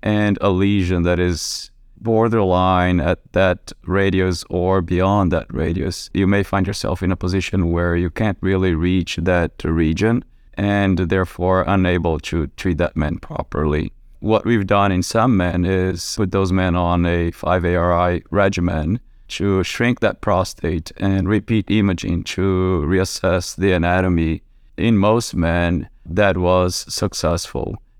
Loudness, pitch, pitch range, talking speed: -19 LUFS, 95 Hz, 85-100 Hz, 145 wpm